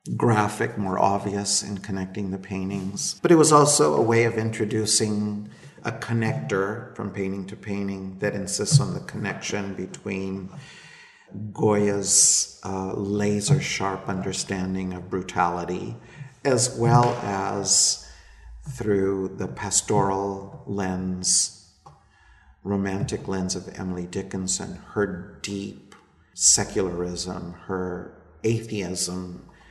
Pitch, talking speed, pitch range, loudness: 100 Hz, 105 wpm, 95-110 Hz, -24 LUFS